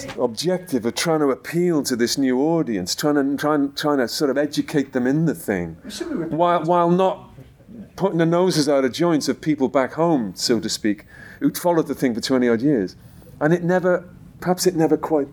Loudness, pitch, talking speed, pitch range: -21 LUFS, 150 Hz, 205 wpm, 135-175 Hz